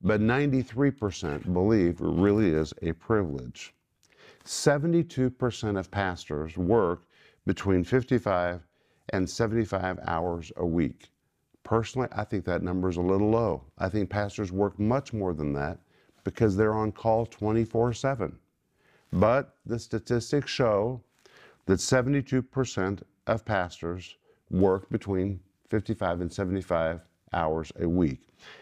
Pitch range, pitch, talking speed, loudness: 90-115 Hz, 100 Hz, 120 wpm, -28 LUFS